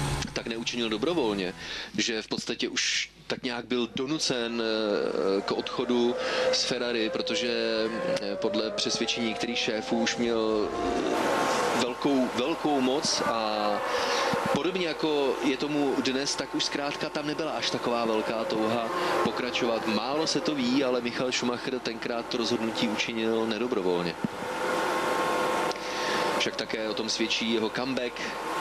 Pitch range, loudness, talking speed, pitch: 110-125 Hz, -28 LUFS, 125 wpm, 120 Hz